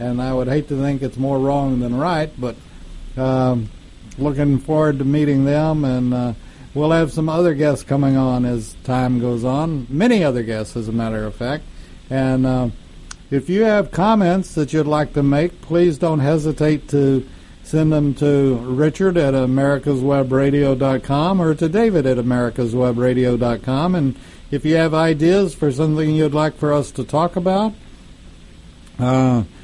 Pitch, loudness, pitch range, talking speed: 140 Hz, -18 LUFS, 125-155 Hz, 160 wpm